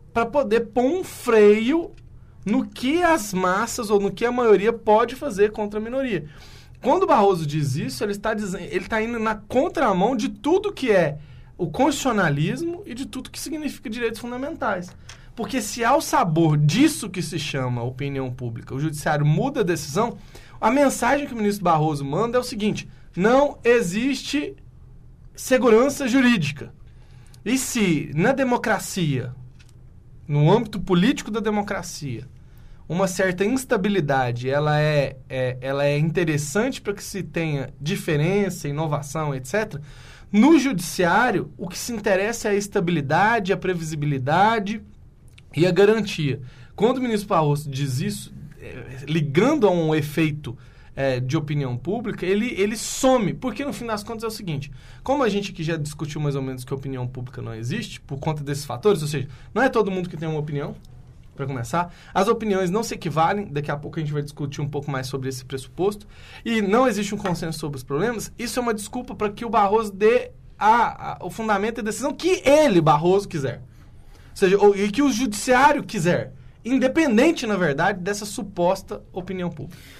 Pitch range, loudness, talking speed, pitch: 145-230 Hz, -22 LUFS, 175 wpm, 190 Hz